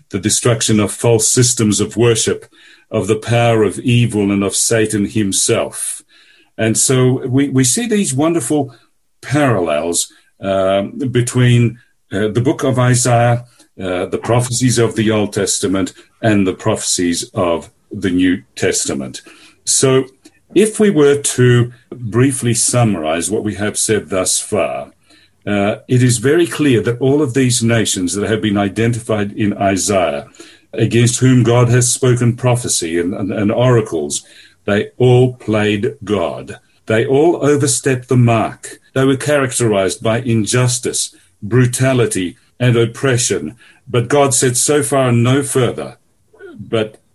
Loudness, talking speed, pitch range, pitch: -14 LUFS, 140 wpm, 105-130 Hz, 120 Hz